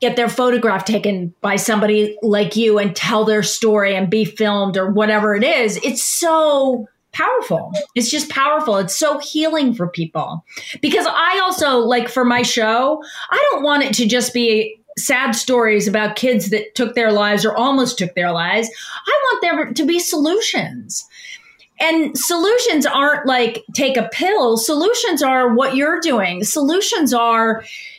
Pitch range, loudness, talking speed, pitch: 215-295 Hz, -16 LUFS, 165 wpm, 245 Hz